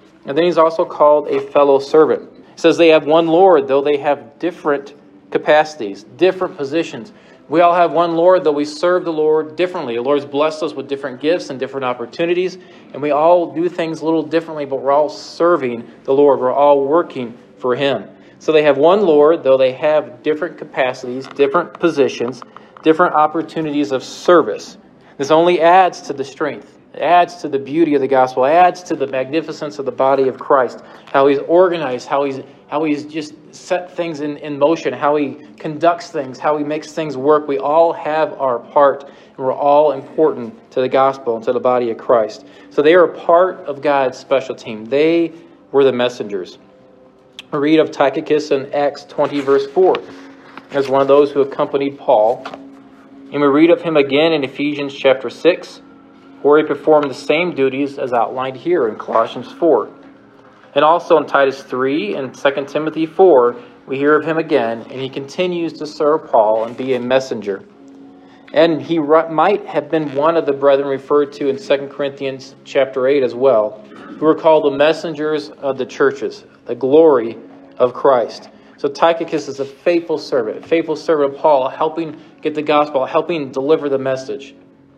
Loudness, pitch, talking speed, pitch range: -16 LUFS, 145 Hz, 185 wpm, 135-160 Hz